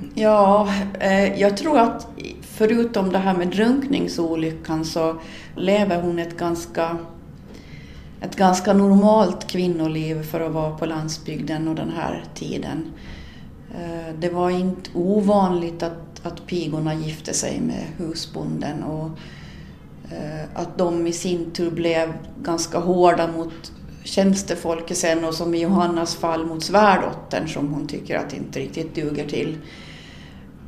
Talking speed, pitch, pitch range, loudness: 125 wpm, 170 Hz, 160-185 Hz, -21 LUFS